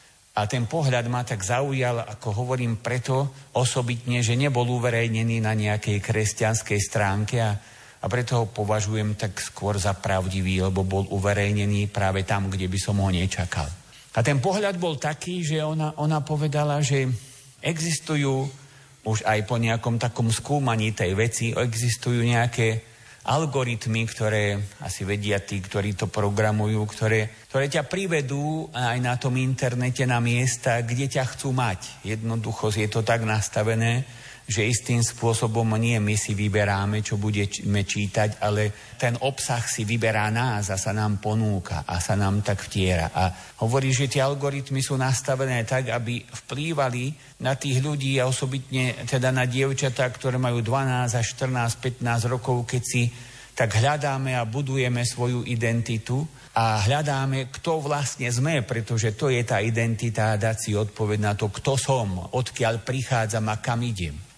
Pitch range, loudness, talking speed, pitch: 105-130 Hz, -25 LUFS, 155 wpm, 120 Hz